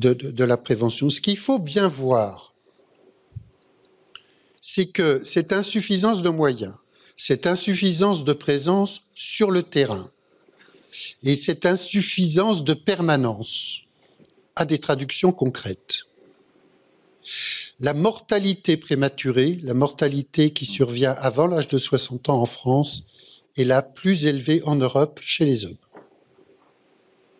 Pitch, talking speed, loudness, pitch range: 150 Hz, 120 wpm, -20 LUFS, 135-195 Hz